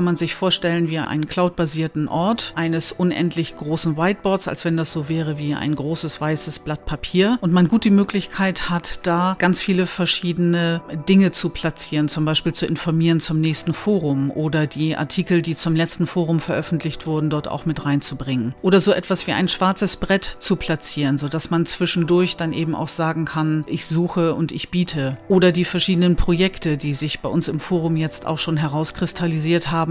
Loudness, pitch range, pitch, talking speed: -19 LUFS, 155-180 Hz, 165 Hz, 185 wpm